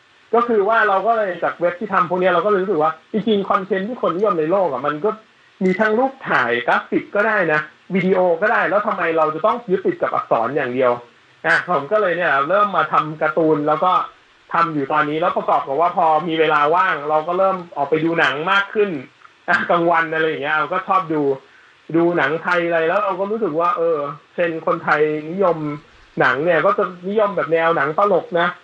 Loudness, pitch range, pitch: -18 LUFS, 155-200 Hz, 175 Hz